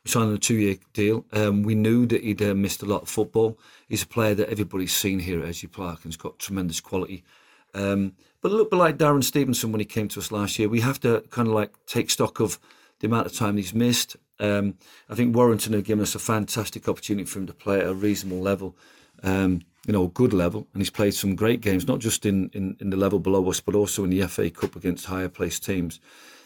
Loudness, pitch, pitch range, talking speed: -24 LUFS, 105 Hz, 95-110 Hz, 245 wpm